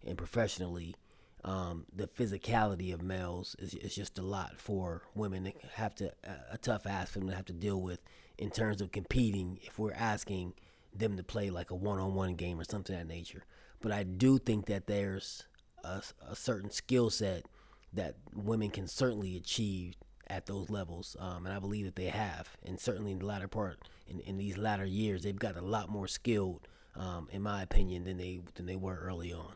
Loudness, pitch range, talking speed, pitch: -37 LUFS, 90-105 Hz, 205 wpm, 95 Hz